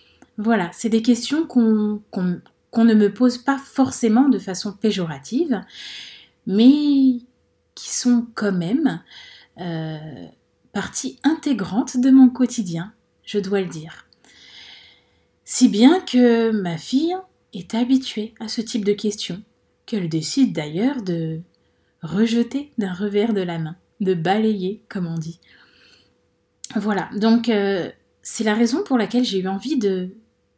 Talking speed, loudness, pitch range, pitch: 135 wpm, -20 LUFS, 190-250 Hz, 220 Hz